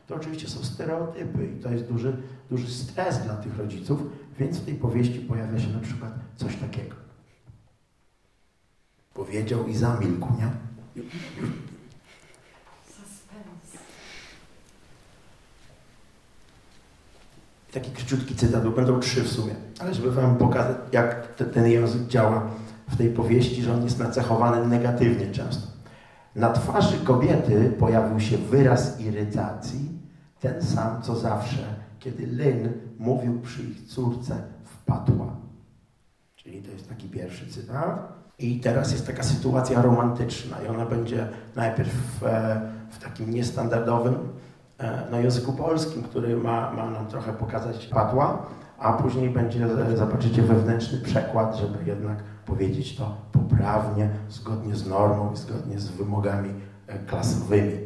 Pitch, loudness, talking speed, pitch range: 120 Hz, -26 LUFS, 125 wpm, 110-130 Hz